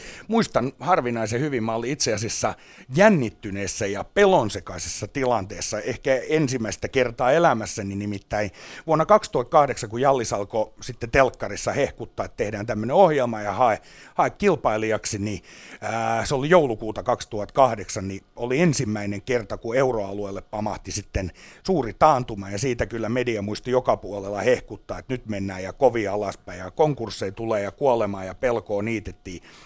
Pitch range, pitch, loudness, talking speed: 100-130 Hz, 115 Hz, -23 LUFS, 140 wpm